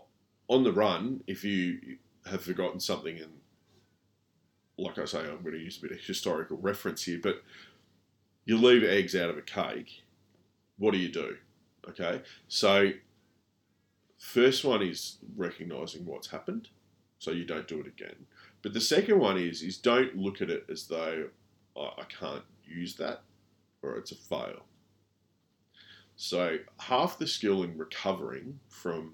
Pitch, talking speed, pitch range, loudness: 100 Hz, 155 wpm, 90-110 Hz, -31 LUFS